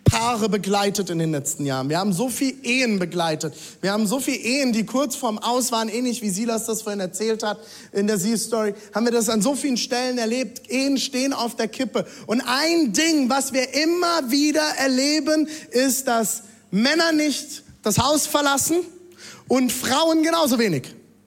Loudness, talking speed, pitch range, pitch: -21 LUFS, 185 wpm, 215-275 Hz, 245 Hz